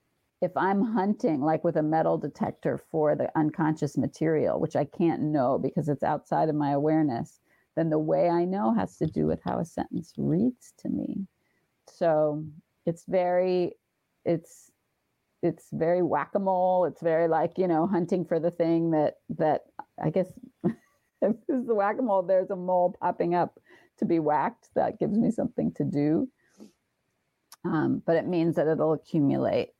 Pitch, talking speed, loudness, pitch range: 170 Hz, 175 wpm, -27 LUFS, 155-190 Hz